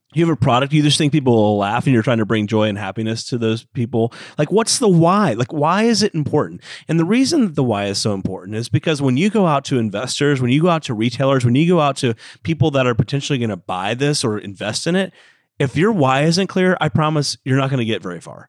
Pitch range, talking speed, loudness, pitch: 115-160 Hz, 275 wpm, -17 LUFS, 140 Hz